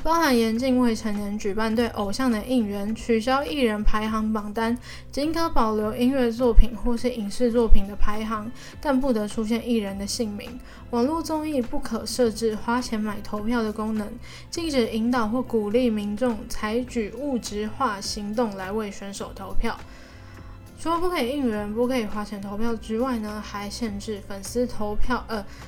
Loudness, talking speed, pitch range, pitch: -26 LUFS, 265 characters per minute, 215-250 Hz, 230 Hz